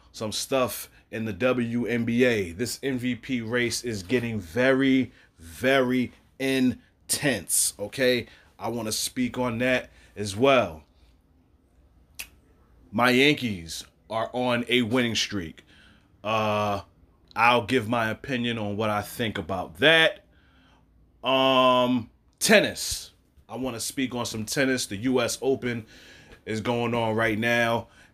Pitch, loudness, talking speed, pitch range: 115 Hz, -25 LUFS, 120 wpm, 100-125 Hz